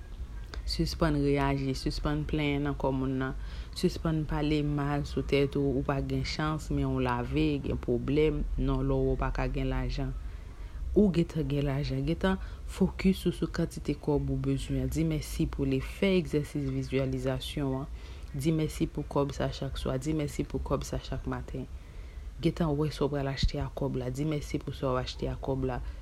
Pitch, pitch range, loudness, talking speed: 140 Hz, 130-150 Hz, -31 LUFS, 185 wpm